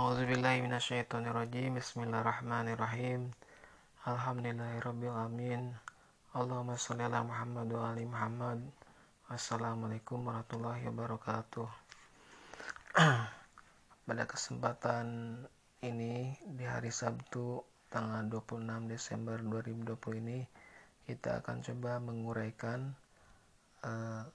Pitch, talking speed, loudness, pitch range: 120 Hz, 70 wpm, -38 LUFS, 115-125 Hz